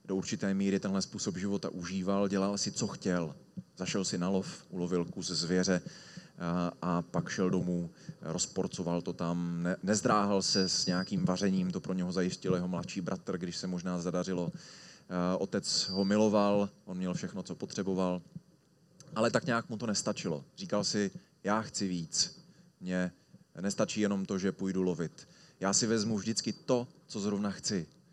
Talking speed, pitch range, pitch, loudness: 160 wpm, 90-100 Hz, 95 Hz, -33 LUFS